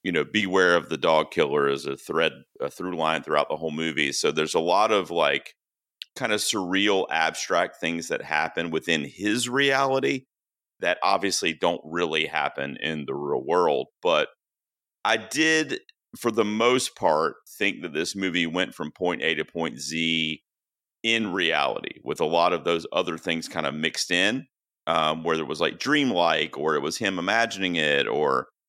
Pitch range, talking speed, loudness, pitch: 80-130 Hz, 180 wpm, -24 LUFS, 95 Hz